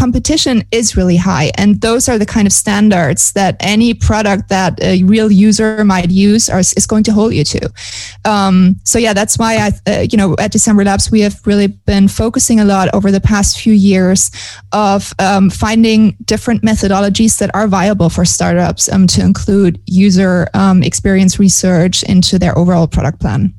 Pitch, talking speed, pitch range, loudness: 195 Hz, 185 wpm, 185-215 Hz, -10 LUFS